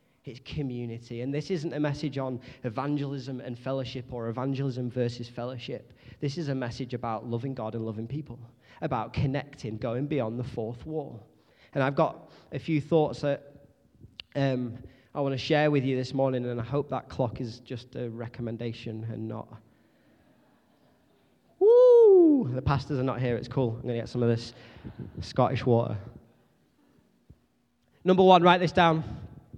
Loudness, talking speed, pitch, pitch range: -27 LUFS, 165 wpm, 130 Hz, 120-140 Hz